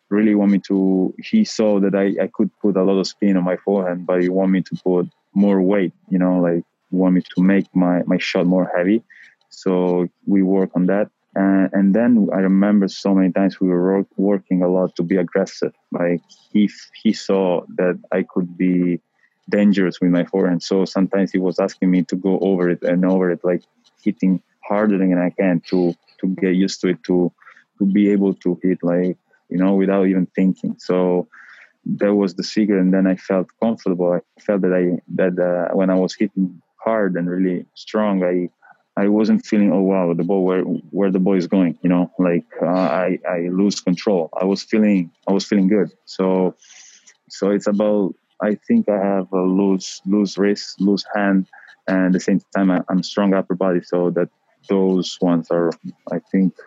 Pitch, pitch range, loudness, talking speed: 95 Hz, 90-100 Hz, -19 LUFS, 205 wpm